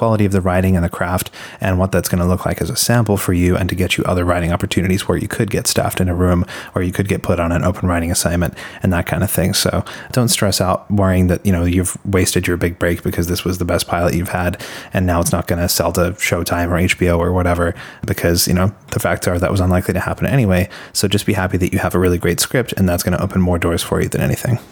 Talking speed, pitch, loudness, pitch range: 285 wpm, 90 Hz, -17 LUFS, 85-95 Hz